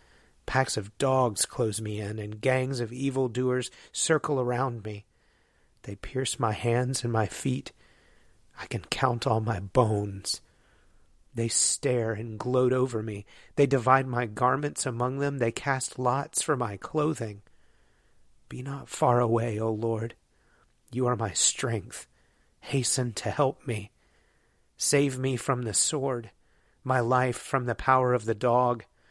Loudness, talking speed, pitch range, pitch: -28 LUFS, 150 wpm, 110-130 Hz, 125 Hz